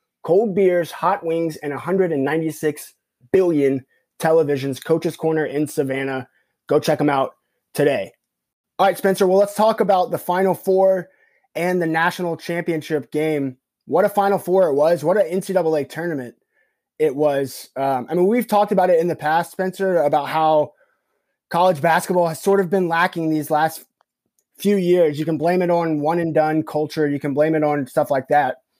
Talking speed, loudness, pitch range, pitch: 175 wpm, -19 LUFS, 150-180 Hz, 160 Hz